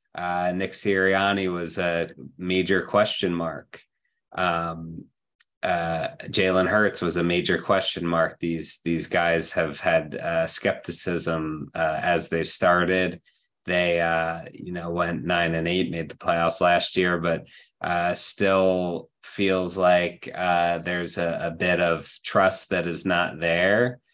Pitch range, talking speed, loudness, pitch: 85-90 Hz, 140 wpm, -24 LUFS, 85 Hz